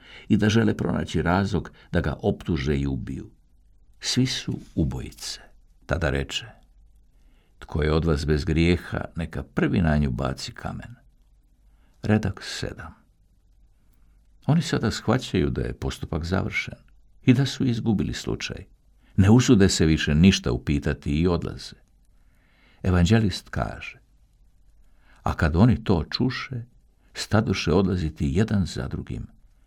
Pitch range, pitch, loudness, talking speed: 80-110 Hz, 90 Hz, -24 LUFS, 125 wpm